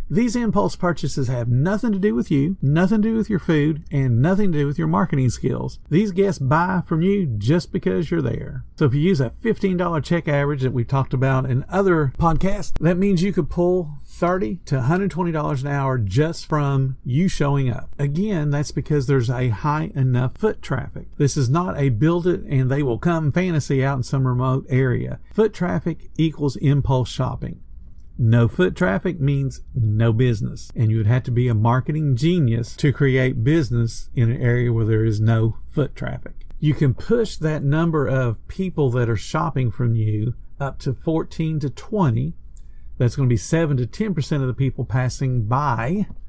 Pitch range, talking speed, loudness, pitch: 130-175 Hz, 190 wpm, -21 LUFS, 145 Hz